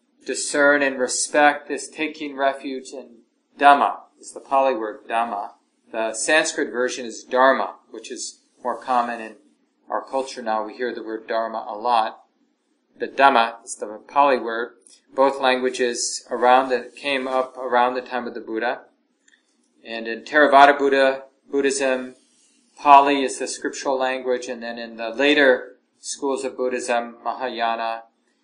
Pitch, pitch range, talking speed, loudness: 130 Hz, 120-140 Hz, 150 wpm, -21 LUFS